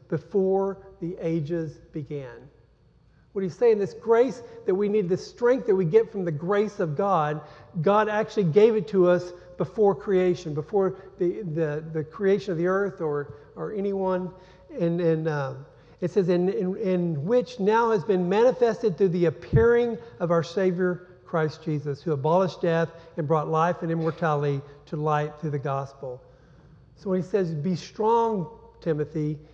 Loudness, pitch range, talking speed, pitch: -25 LUFS, 155-200 Hz, 165 wpm, 180 Hz